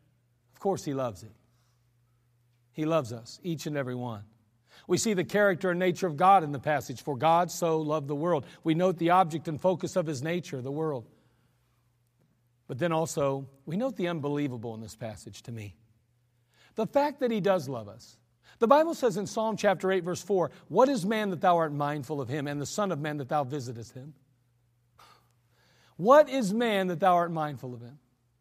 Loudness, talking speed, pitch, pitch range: -28 LUFS, 200 wpm, 150 Hz, 120-180 Hz